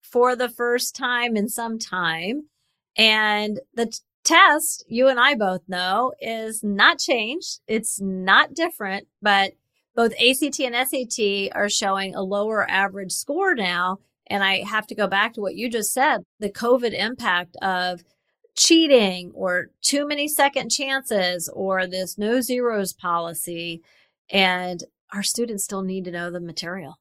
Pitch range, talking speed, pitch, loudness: 190-250 Hz, 155 wpm, 210 Hz, -21 LUFS